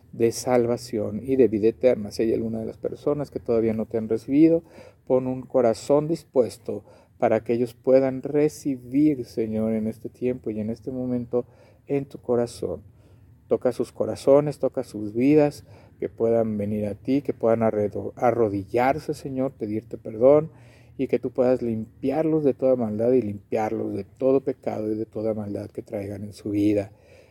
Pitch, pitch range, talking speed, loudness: 120 Hz, 110-130 Hz, 170 wpm, -24 LUFS